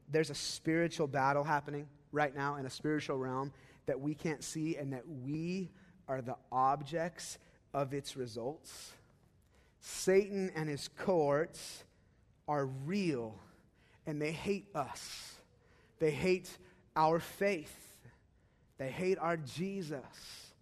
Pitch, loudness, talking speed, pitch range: 150 Hz, -37 LUFS, 120 wpm, 135-170 Hz